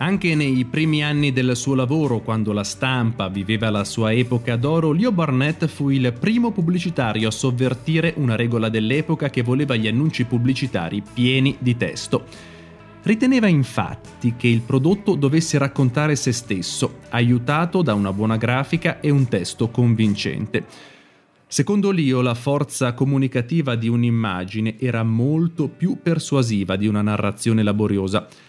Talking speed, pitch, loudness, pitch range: 140 wpm, 130 Hz, -20 LUFS, 110-150 Hz